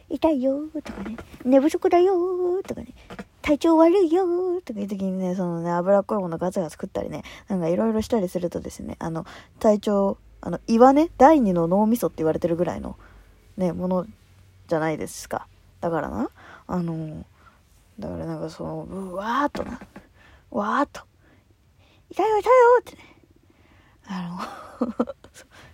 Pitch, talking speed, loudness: 215 Hz, 310 characters per minute, -23 LUFS